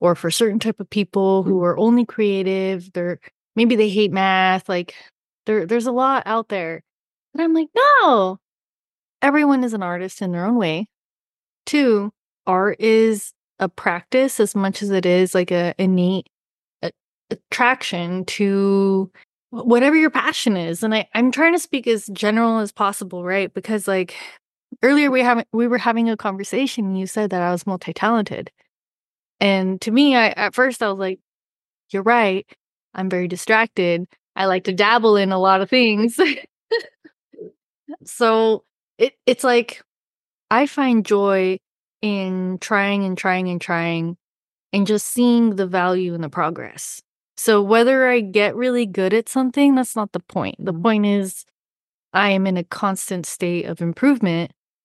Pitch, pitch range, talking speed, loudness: 205 Hz, 185-235 Hz, 160 wpm, -19 LUFS